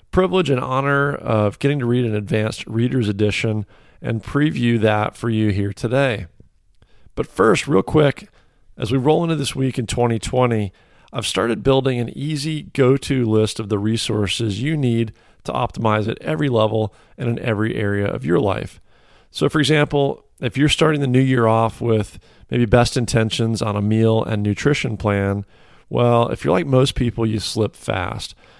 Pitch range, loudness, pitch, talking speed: 110-135 Hz, -19 LUFS, 120 Hz, 175 wpm